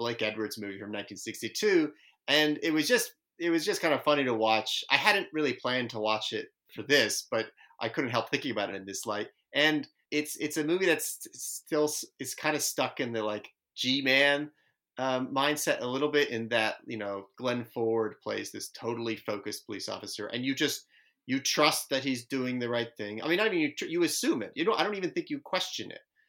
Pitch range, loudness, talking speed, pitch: 110-155 Hz, -30 LUFS, 220 wpm, 135 Hz